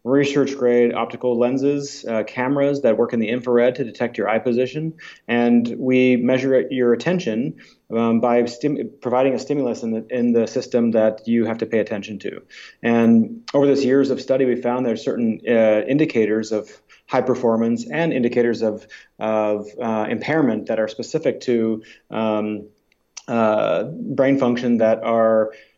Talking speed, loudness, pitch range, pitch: 160 wpm, -20 LUFS, 110-130 Hz, 120 Hz